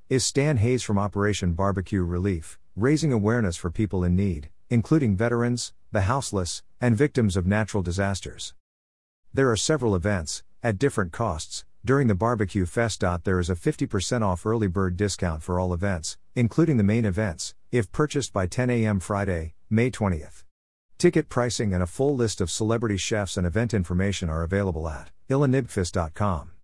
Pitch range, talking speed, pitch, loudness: 90-115 Hz, 160 wpm, 100 Hz, -25 LUFS